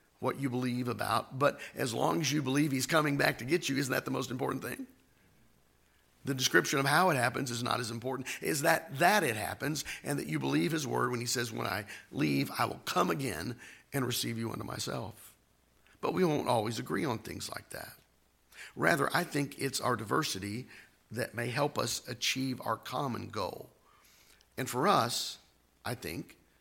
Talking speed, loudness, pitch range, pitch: 195 wpm, -32 LUFS, 105-135 Hz, 125 Hz